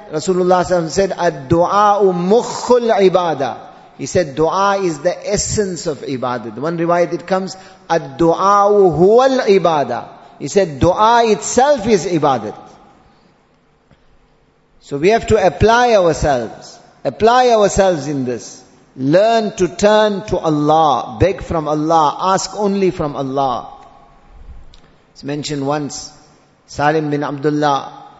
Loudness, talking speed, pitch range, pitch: -15 LUFS, 115 wpm, 150-200 Hz, 175 Hz